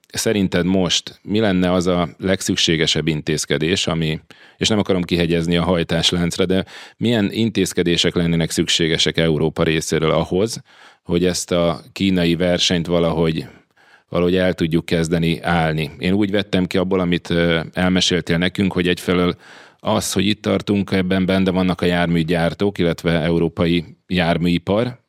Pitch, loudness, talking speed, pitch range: 90 Hz, -18 LUFS, 135 wpm, 85-95 Hz